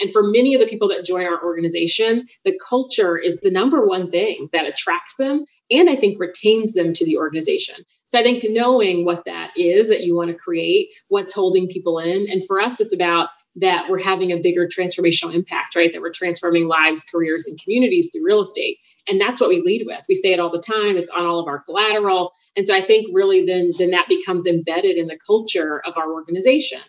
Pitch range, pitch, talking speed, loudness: 170-245 Hz, 185 Hz, 225 wpm, -18 LUFS